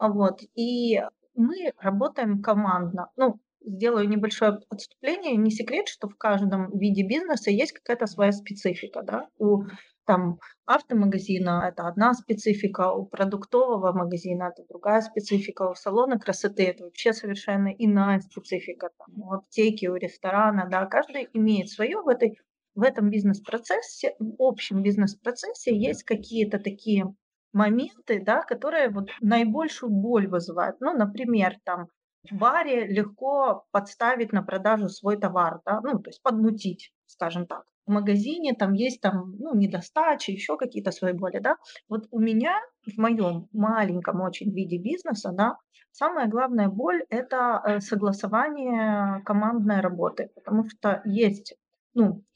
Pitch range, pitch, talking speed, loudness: 195-235 Hz, 210 Hz, 135 wpm, -26 LUFS